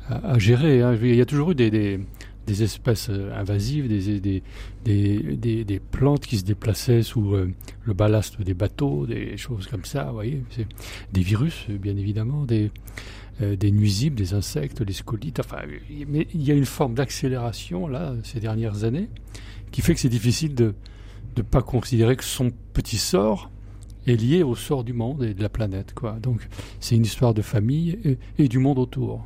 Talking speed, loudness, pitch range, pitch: 195 wpm, -24 LUFS, 100-125 Hz, 110 Hz